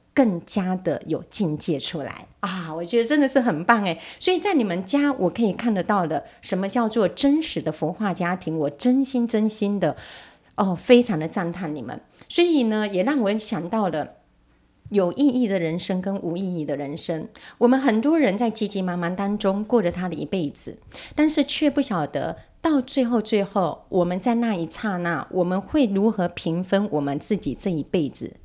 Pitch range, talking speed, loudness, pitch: 170-240 Hz, 275 characters per minute, -23 LUFS, 200 Hz